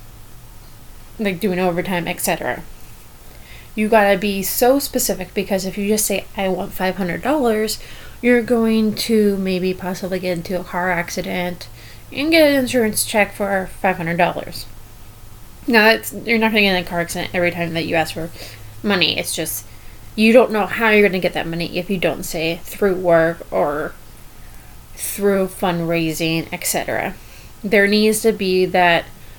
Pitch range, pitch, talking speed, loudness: 165-210 Hz, 185 Hz, 170 wpm, -18 LUFS